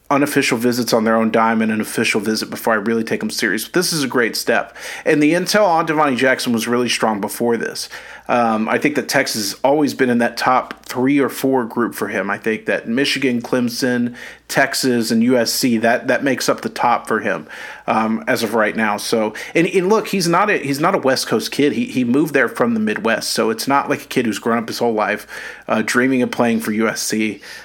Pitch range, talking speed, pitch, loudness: 115-145 Hz, 230 wpm, 125 Hz, -17 LUFS